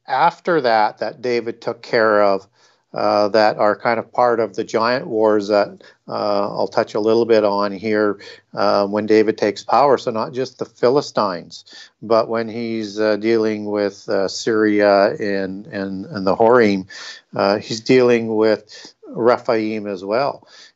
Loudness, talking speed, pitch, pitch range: -18 LUFS, 160 wpm, 110 Hz, 100-115 Hz